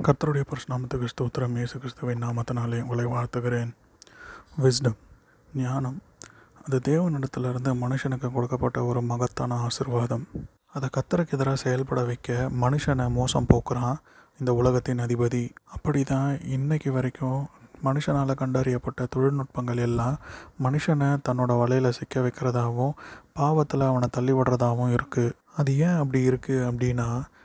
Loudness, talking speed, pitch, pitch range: -26 LUFS, 110 wpm, 130 Hz, 120-135 Hz